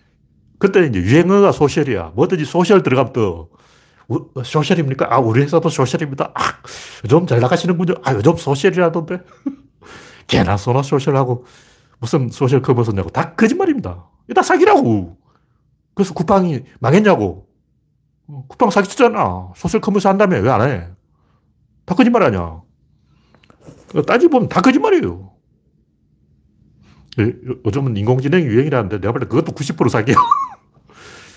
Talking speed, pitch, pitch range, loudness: 300 characters per minute, 140 Hz, 120-180 Hz, -16 LUFS